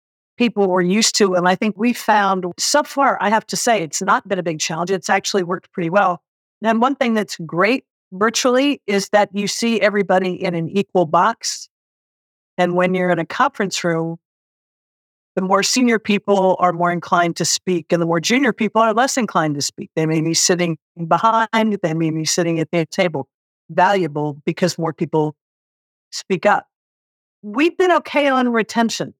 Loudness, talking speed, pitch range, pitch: -18 LUFS, 185 wpm, 170-220 Hz, 190 Hz